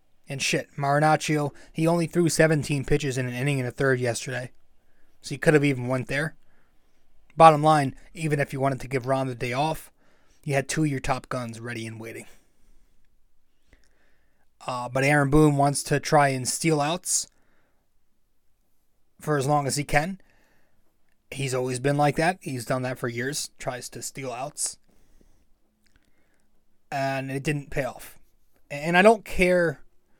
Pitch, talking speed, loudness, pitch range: 140 Hz, 165 wpm, -24 LUFS, 130-155 Hz